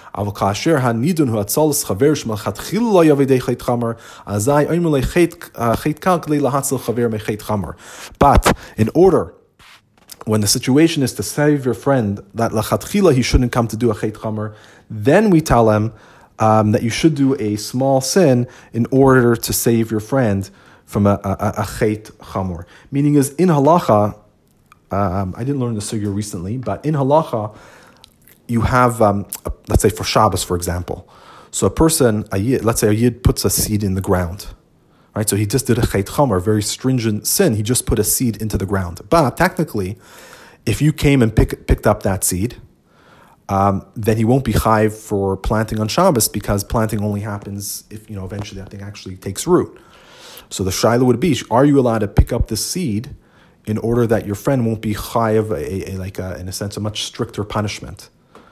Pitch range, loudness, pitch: 105-130 Hz, -17 LUFS, 110 Hz